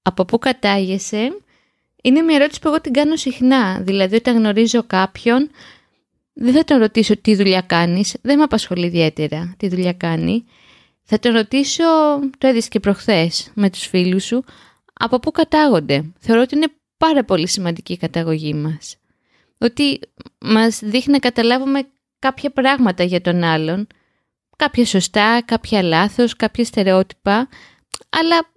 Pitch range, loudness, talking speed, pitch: 190-265 Hz, -16 LUFS, 145 wpm, 225 Hz